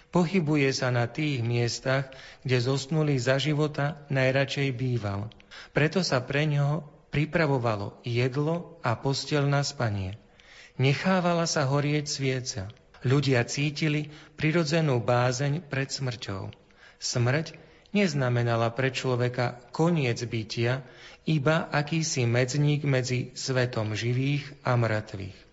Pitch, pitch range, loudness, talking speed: 135 Hz, 125-150 Hz, -27 LUFS, 105 wpm